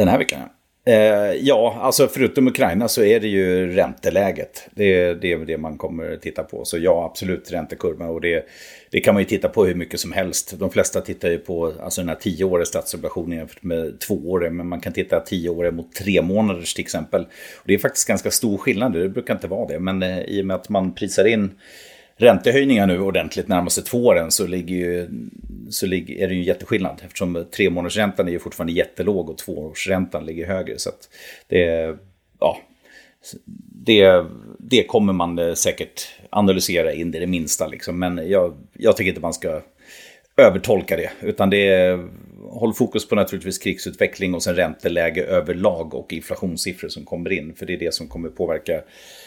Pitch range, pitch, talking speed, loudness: 85-100 Hz, 90 Hz, 190 wpm, -20 LUFS